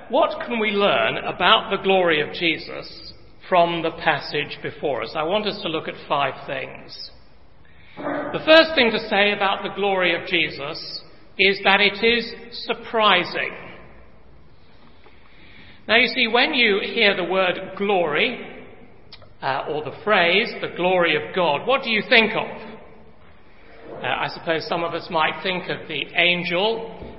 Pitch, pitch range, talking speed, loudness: 195 Hz, 170-225 Hz, 155 wpm, -20 LUFS